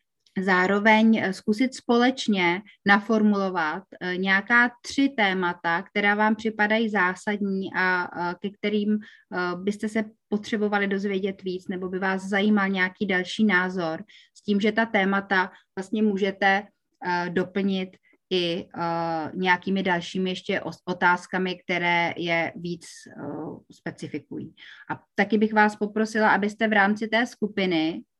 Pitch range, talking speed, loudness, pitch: 180-215 Hz, 115 wpm, -24 LUFS, 195 Hz